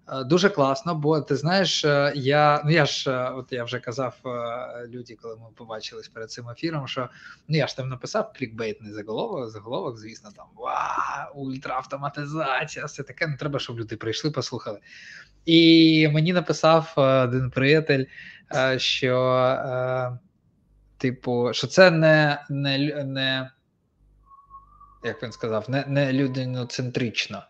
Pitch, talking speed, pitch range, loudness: 135 Hz, 130 wpm, 125-155 Hz, -23 LUFS